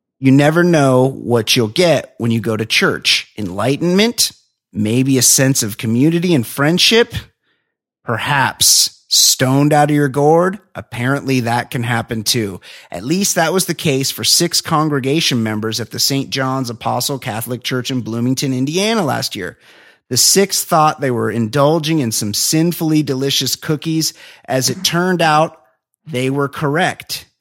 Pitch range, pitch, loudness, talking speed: 120-155 Hz, 135 Hz, -14 LUFS, 155 wpm